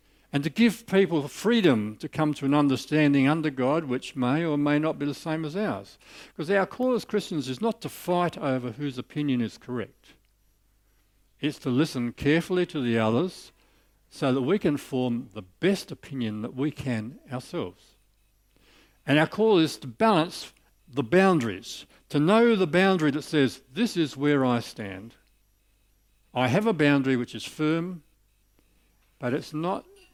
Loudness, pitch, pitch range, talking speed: -26 LUFS, 145 Hz, 120-165 Hz, 165 wpm